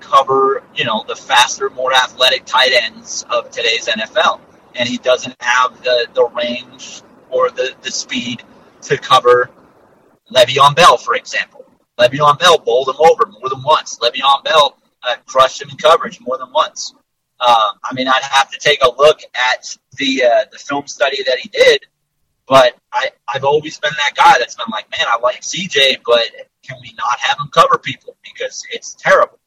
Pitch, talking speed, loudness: 165 Hz, 185 wpm, -13 LUFS